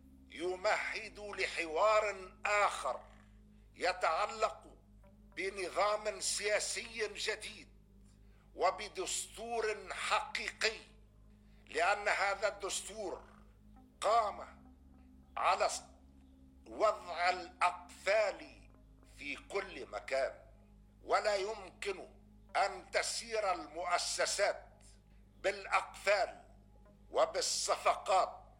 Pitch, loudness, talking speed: 185 Hz, -35 LUFS, 55 wpm